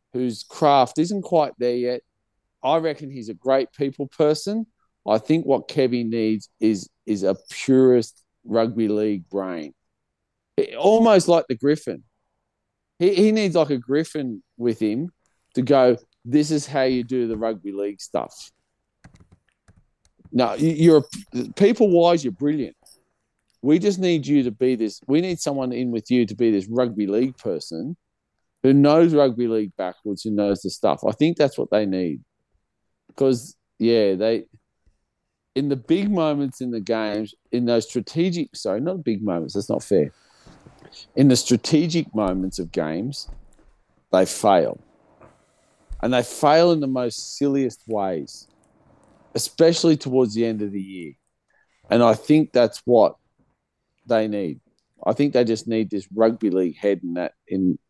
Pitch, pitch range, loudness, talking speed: 125 Hz, 110-150 Hz, -21 LUFS, 155 wpm